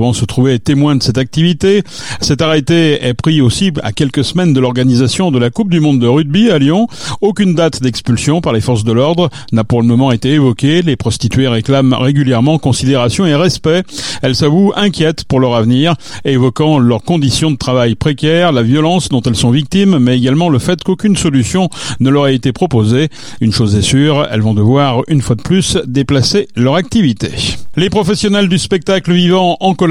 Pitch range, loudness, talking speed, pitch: 125-170 Hz, -11 LUFS, 195 wpm, 140 Hz